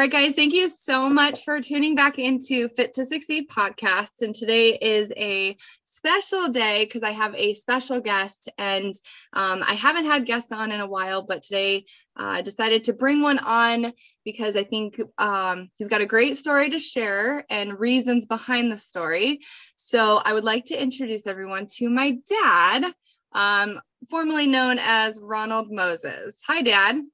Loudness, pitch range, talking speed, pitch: -22 LUFS, 210-275 Hz, 175 wpm, 235 Hz